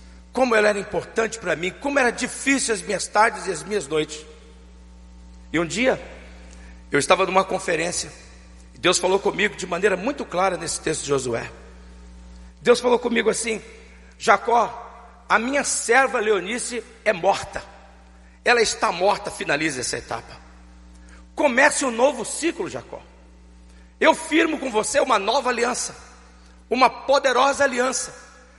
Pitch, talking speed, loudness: 190 Hz, 140 wpm, -21 LUFS